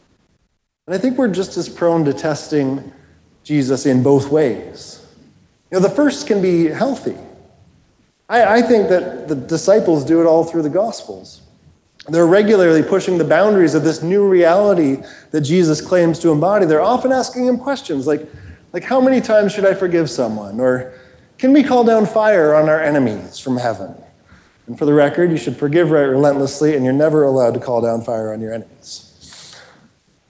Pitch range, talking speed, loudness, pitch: 140-195 Hz, 180 wpm, -15 LUFS, 160 Hz